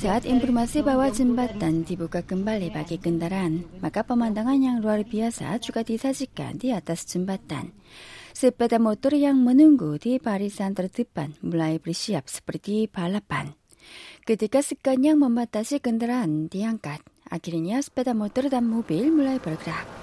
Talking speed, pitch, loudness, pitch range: 125 wpm, 220 Hz, -24 LUFS, 175-255 Hz